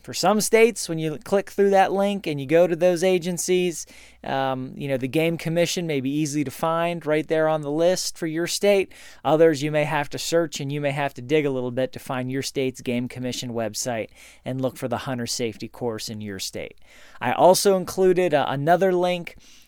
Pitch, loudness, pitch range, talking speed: 155 Hz, -23 LUFS, 130-180 Hz, 220 wpm